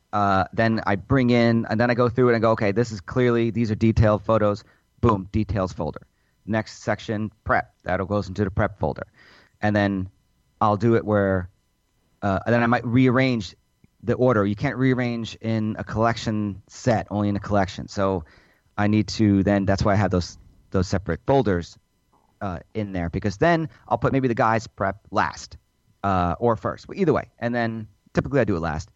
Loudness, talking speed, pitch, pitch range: -23 LUFS, 200 wpm, 105 Hz, 95-115 Hz